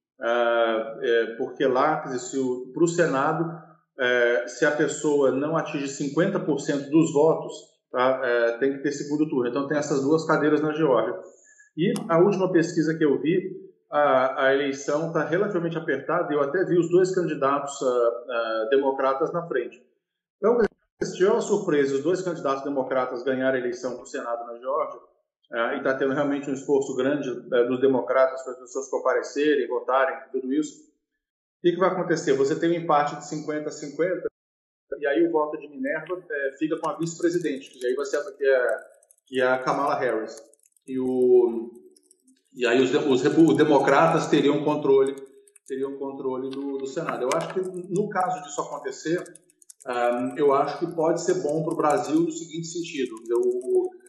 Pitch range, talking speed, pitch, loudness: 135-180 Hz, 180 wpm, 150 Hz, -24 LUFS